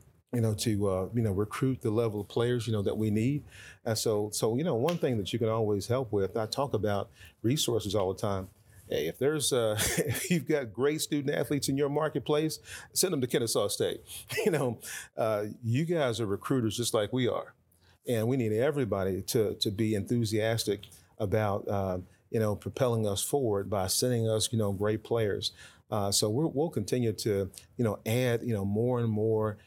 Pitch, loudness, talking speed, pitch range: 110 Hz, -30 LUFS, 200 wpm, 105-125 Hz